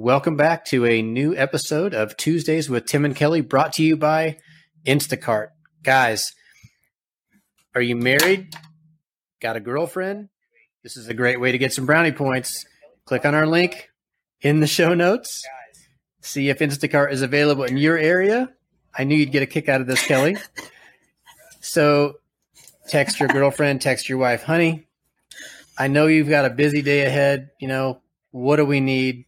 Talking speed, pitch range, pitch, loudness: 170 wpm, 130-160 Hz, 145 Hz, -19 LUFS